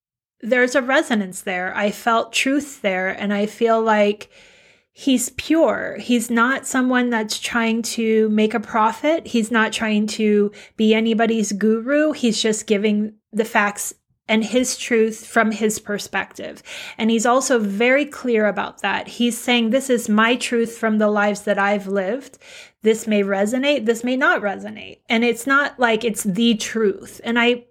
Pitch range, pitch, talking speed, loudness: 215-245 Hz, 225 Hz, 165 wpm, -19 LUFS